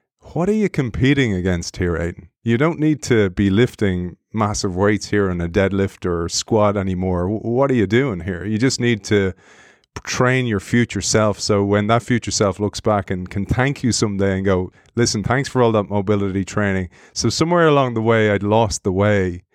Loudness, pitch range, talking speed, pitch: -19 LUFS, 95-120 Hz, 200 wpm, 105 Hz